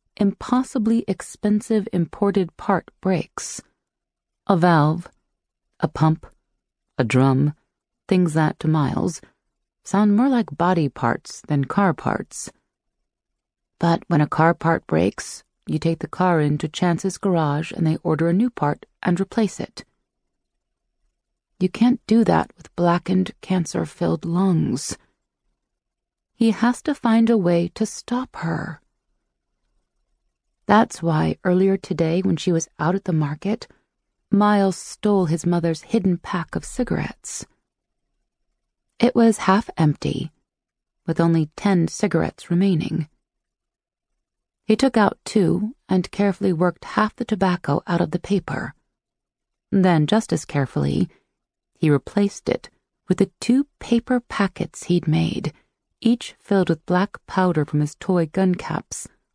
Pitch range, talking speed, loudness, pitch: 165-210 Hz, 130 wpm, -21 LUFS, 185 Hz